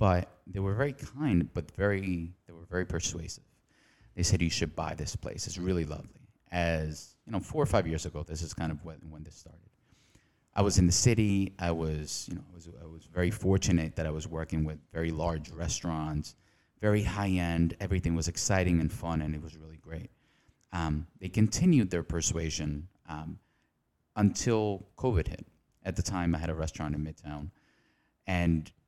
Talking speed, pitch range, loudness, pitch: 190 wpm, 80-95 Hz, -31 LUFS, 85 Hz